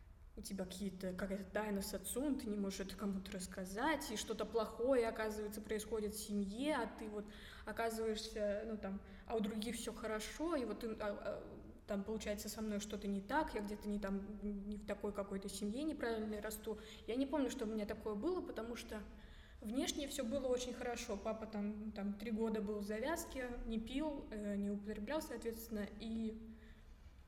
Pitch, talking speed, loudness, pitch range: 215 Hz, 175 wpm, -43 LUFS, 205-230 Hz